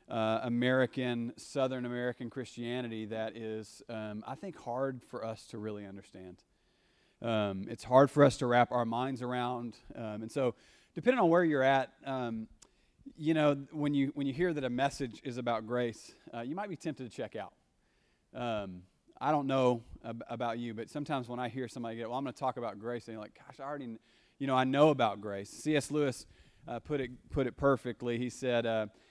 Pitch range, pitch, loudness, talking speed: 115-135 Hz, 120 Hz, -33 LUFS, 205 wpm